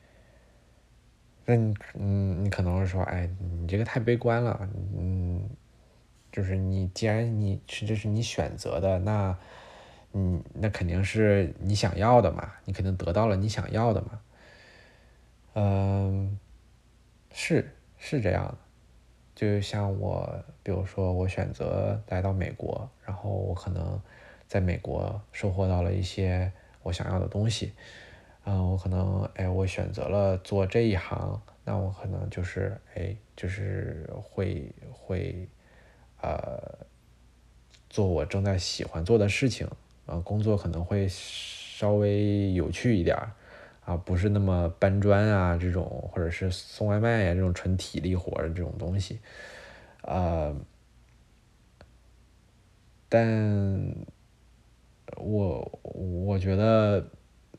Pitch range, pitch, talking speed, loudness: 90-105 Hz, 95 Hz, 185 characters per minute, -29 LUFS